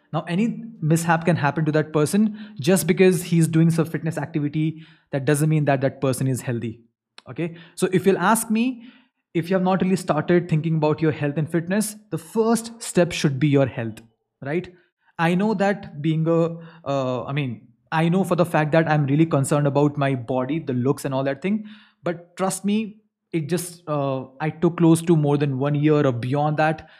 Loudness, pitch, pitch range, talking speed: -22 LUFS, 160 Hz, 145-185 Hz, 205 wpm